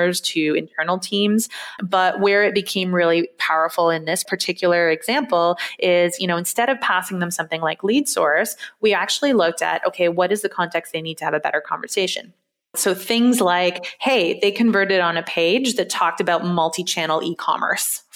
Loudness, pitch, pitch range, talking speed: -19 LUFS, 180 Hz, 170-205 Hz, 185 wpm